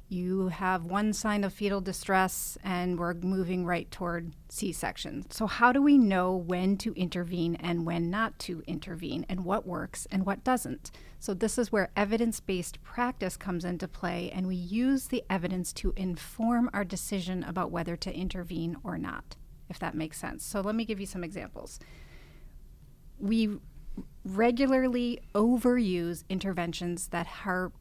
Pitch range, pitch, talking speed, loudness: 175-210 Hz, 185 Hz, 160 wpm, -31 LUFS